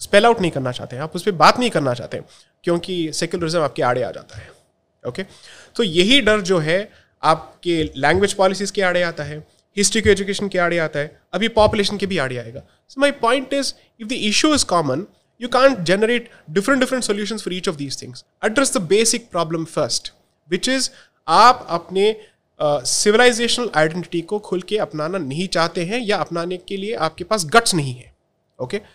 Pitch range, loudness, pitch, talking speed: 165-220 Hz, -19 LUFS, 190 Hz, 205 wpm